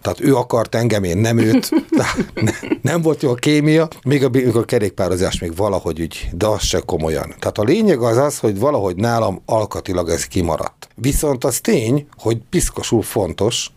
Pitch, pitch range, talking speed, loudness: 115 Hz, 100-145 Hz, 185 wpm, -17 LUFS